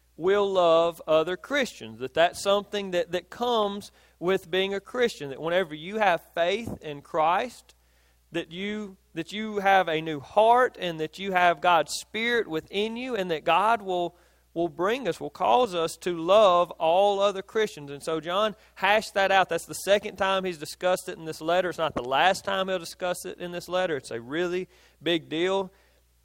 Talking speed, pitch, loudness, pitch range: 190 wpm, 180 Hz, -26 LUFS, 160-200 Hz